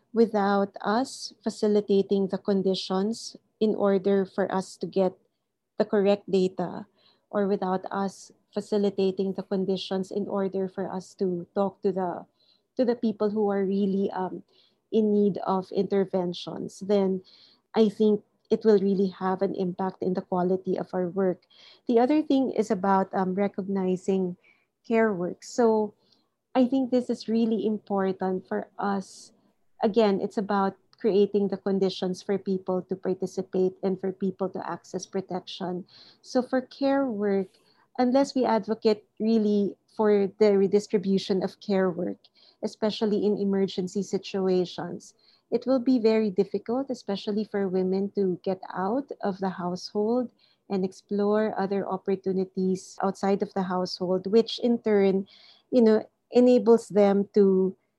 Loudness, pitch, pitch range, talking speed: -26 LUFS, 200 Hz, 190-215 Hz, 140 wpm